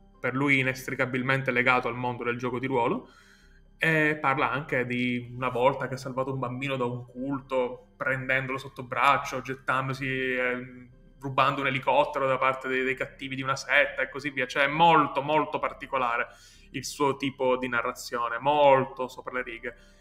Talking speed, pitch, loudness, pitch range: 170 wpm, 130 Hz, -27 LUFS, 125-135 Hz